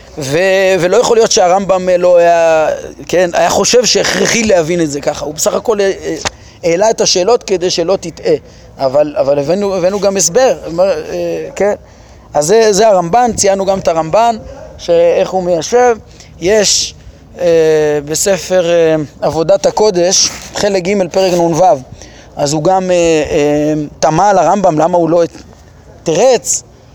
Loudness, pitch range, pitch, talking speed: -11 LUFS, 165-210 Hz, 185 Hz, 130 wpm